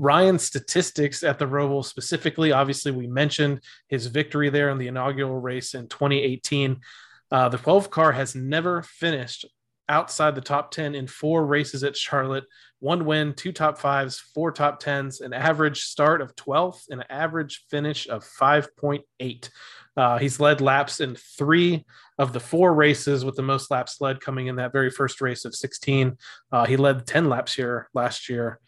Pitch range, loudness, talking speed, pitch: 130-150 Hz, -23 LUFS, 175 wpm, 140 Hz